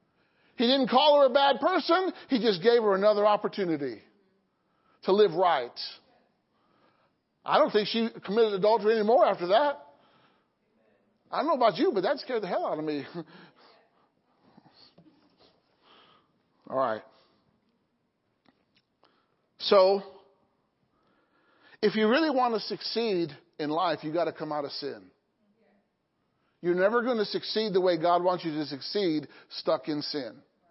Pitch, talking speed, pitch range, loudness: 210 Hz, 140 wpm, 175-240 Hz, -26 LUFS